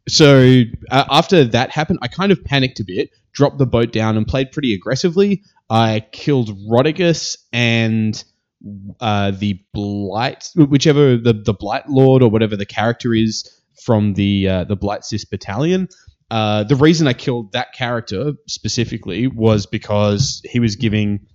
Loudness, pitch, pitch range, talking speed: -16 LUFS, 115 Hz, 105-140 Hz, 155 wpm